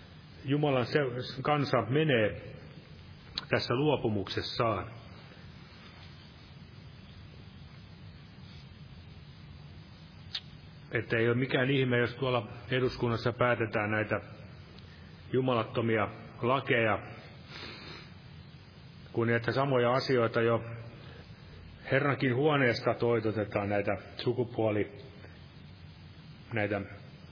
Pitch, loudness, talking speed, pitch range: 115 Hz, -30 LUFS, 60 wpm, 105-130 Hz